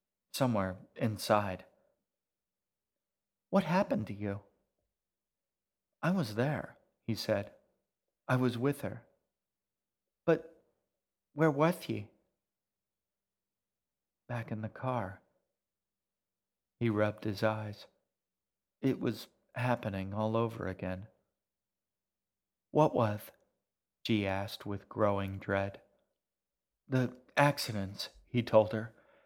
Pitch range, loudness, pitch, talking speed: 100-125 Hz, -34 LUFS, 110 Hz, 90 wpm